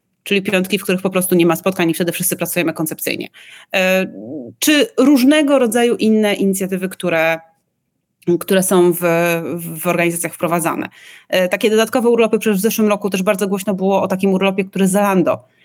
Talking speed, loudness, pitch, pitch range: 160 wpm, -16 LUFS, 190 Hz, 170-205 Hz